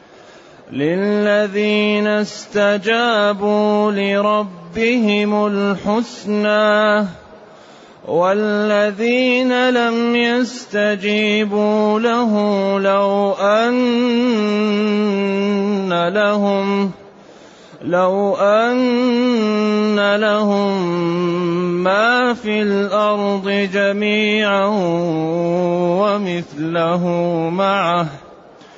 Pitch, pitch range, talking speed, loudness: 205 Hz, 195-210 Hz, 40 wpm, -16 LUFS